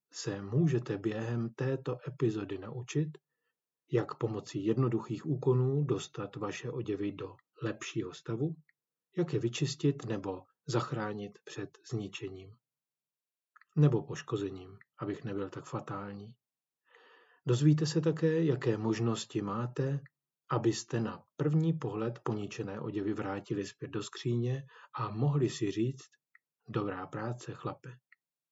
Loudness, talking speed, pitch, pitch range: -34 LUFS, 110 wpm, 120 Hz, 110-145 Hz